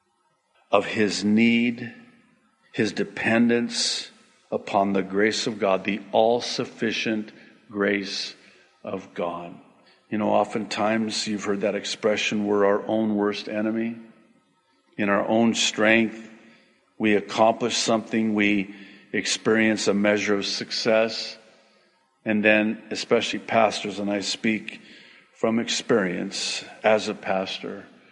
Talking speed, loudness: 115 wpm, -23 LUFS